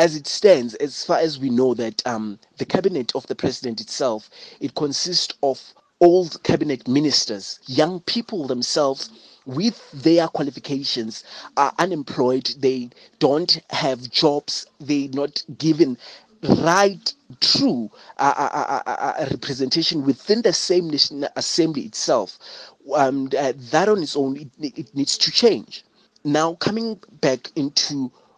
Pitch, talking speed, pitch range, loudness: 145 Hz, 135 wpm, 135-165 Hz, -21 LUFS